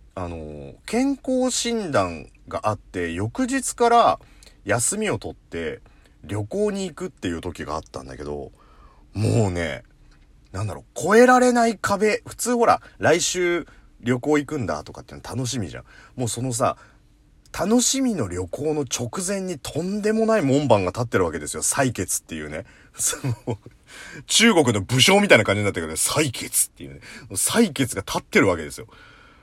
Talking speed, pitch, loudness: 310 characters per minute, 130 Hz, -22 LUFS